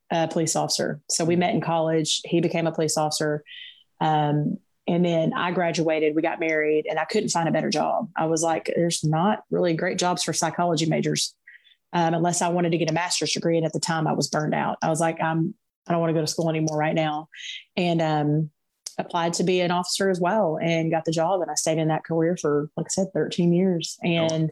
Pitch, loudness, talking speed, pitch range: 165 Hz, -24 LUFS, 235 wpm, 160-175 Hz